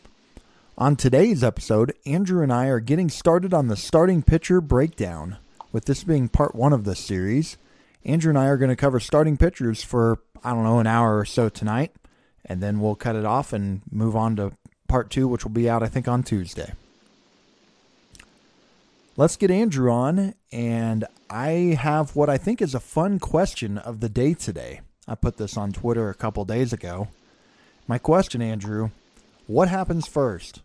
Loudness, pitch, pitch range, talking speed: -23 LUFS, 125 Hz, 110-150 Hz, 180 wpm